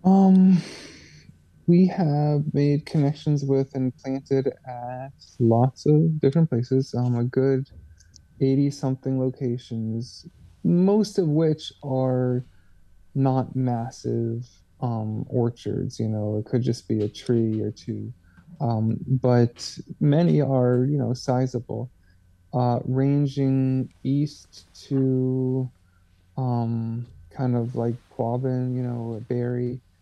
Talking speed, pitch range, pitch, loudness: 110 wpm, 115-135 Hz, 125 Hz, -24 LUFS